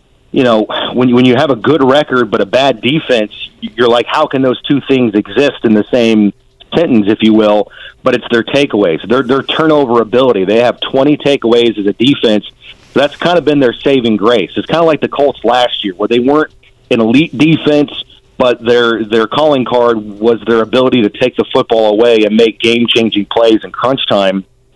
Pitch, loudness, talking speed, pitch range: 120 Hz, -10 LUFS, 210 wpm, 110-135 Hz